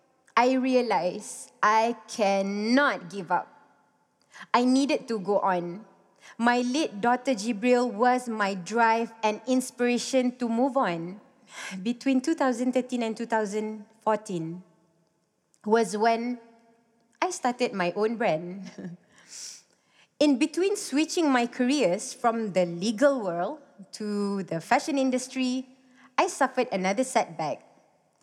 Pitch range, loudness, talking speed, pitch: 205-255 Hz, -26 LUFS, 110 wpm, 230 Hz